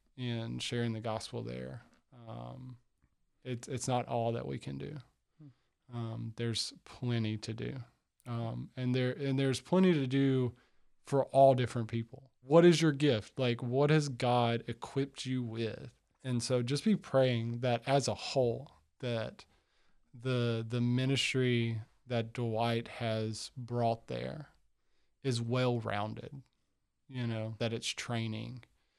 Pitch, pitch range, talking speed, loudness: 120 Hz, 115-130 Hz, 140 wpm, -33 LUFS